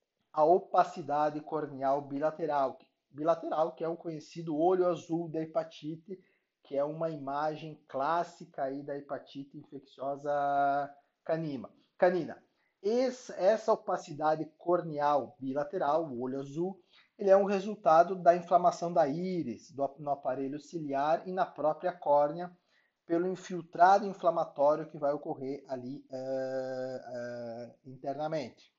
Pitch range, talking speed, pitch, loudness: 140-175 Hz, 115 wpm, 155 Hz, -32 LUFS